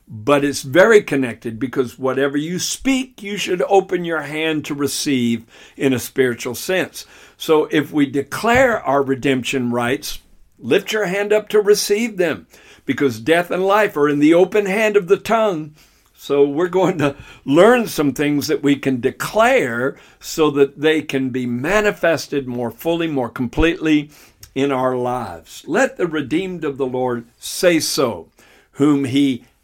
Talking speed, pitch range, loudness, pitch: 160 wpm, 130-180 Hz, -18 LUFS, 145 Hz